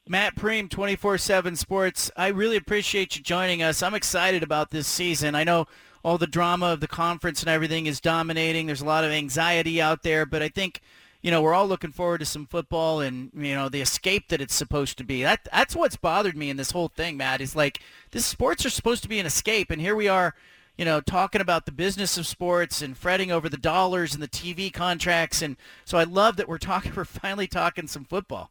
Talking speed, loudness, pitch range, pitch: 235 wpm, -25 LUFS, 155-185 Hz, 170 Hz